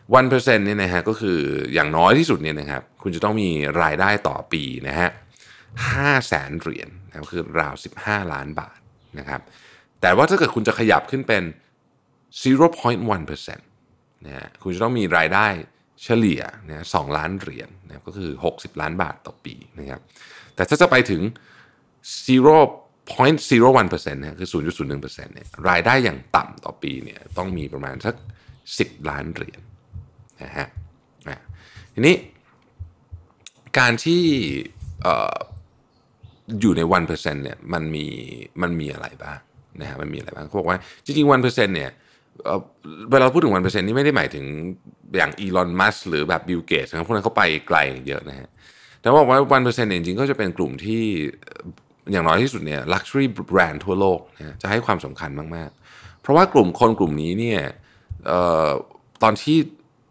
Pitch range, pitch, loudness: 80-125 Hz, 100 Hz, -20 LUFS